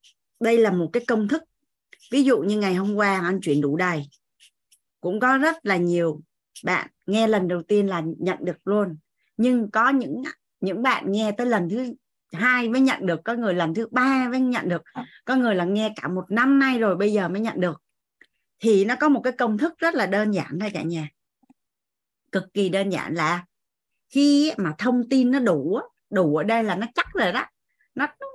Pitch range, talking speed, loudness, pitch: 180-255 Hz, 210 wpm, -23 LUFS, 210 Hz